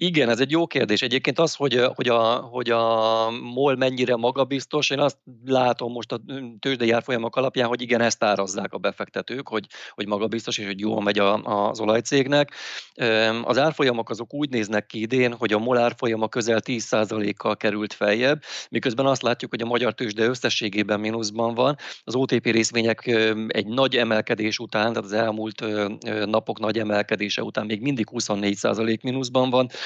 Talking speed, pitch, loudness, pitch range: 165 wpm, 115 Hz, -23 LUFS, 110-125 Hz